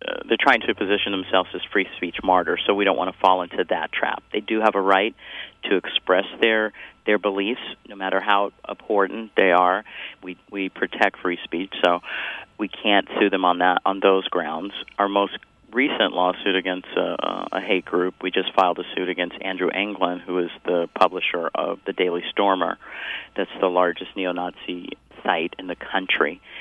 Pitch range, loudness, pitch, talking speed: 90-100 Hz, -22 LUFS, 95 Hz, 185 wpm